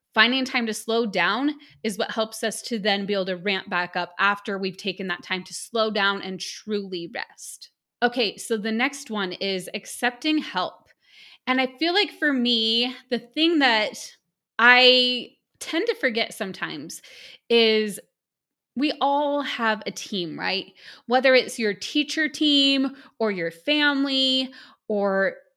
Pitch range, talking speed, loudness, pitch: 200-265 Hz, 155 wpm, -23 LUFS, 230 Hz